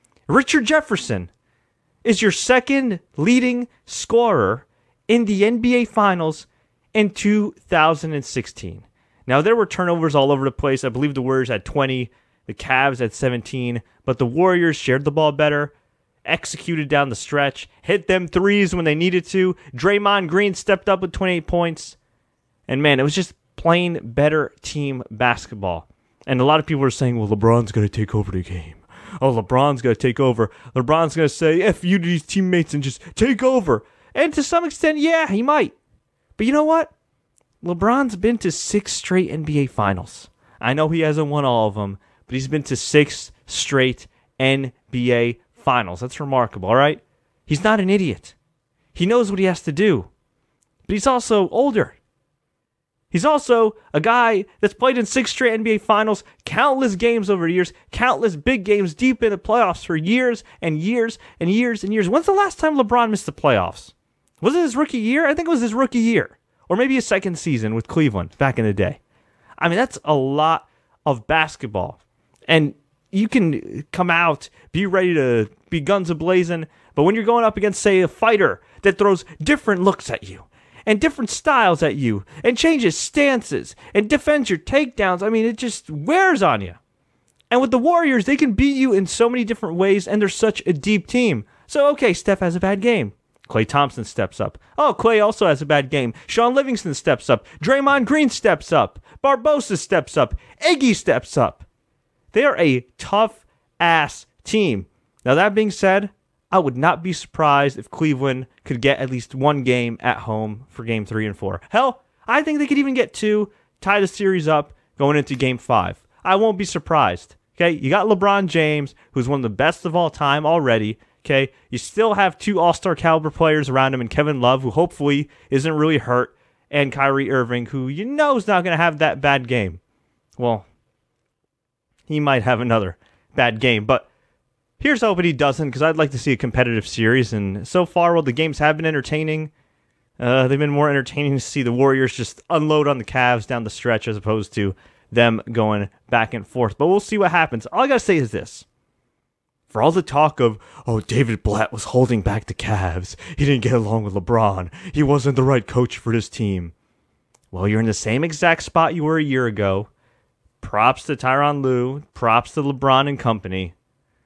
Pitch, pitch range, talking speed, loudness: 155 Hz, 125-205 Hz, 190 wpm, -19 LUFS